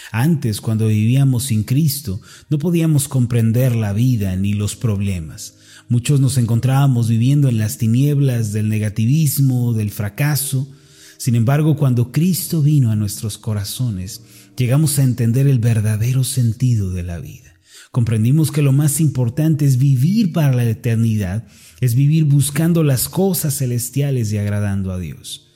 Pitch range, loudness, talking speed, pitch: 110-140 Hz, -17 LUFS, 145 wpm, 125 Hz